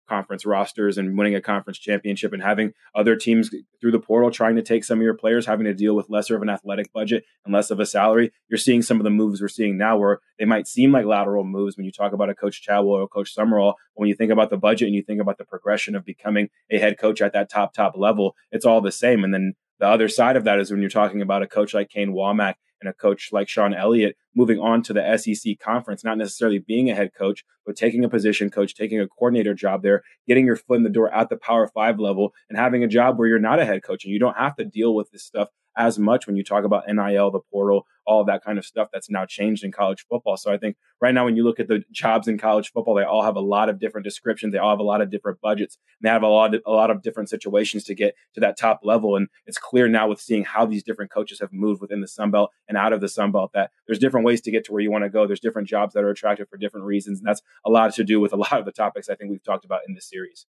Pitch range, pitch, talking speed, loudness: 100-110 Hz, 105 Hz, 290 wpm, -21 LUFS